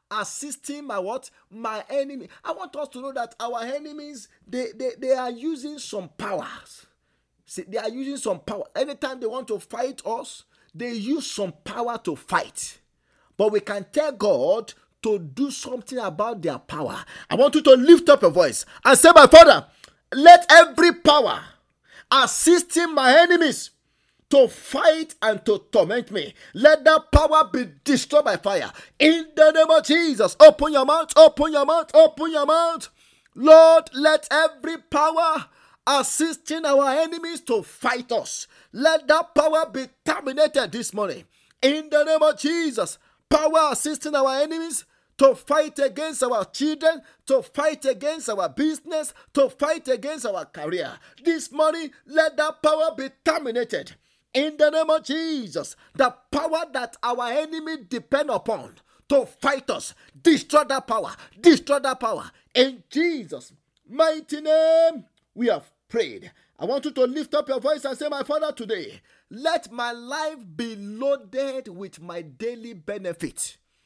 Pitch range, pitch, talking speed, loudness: 245-315 Hz, 285 Hz, 155 wpm, -19 LUFS